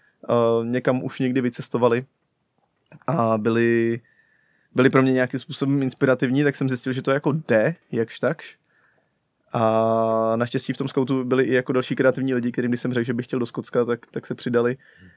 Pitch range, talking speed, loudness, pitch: 120-135 Hz, 180 wpm, -22 LUFS, 125 Hz